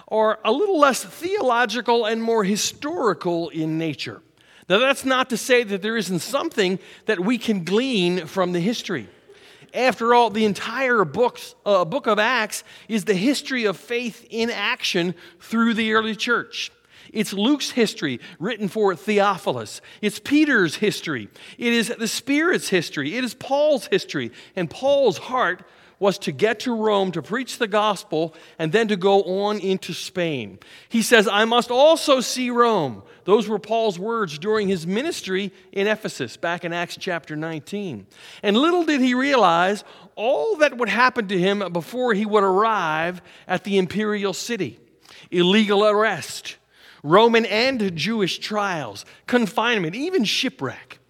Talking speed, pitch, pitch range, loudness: 155 wpm, 215 Hz, 185-240 Hz, -21 LUFS